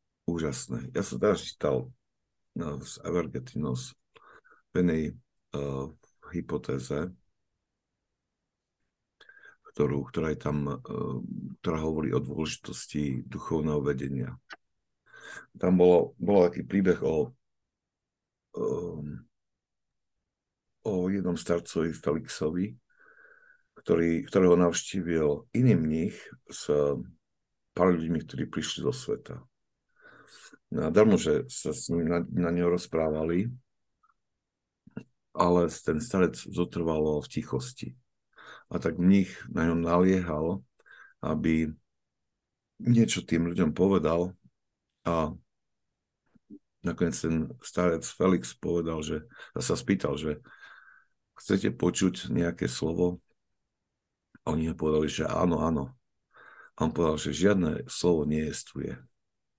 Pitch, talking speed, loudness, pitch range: 80 Hz, 100 wpm, -29 LUFS, 75-90 Hz